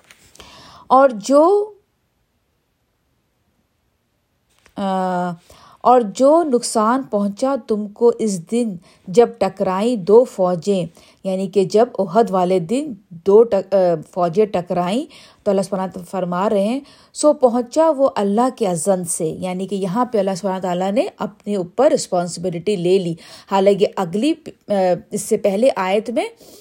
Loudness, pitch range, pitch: -18 LUFS, 190-240 Hz, 205 Hz